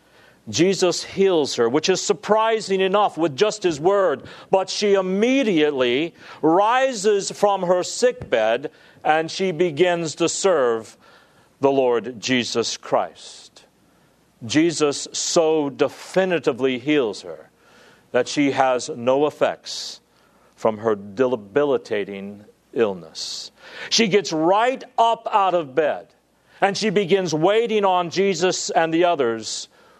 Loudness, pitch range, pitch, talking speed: -20 LUFS, 140-195 Hz, 175 Hz, 115 wpm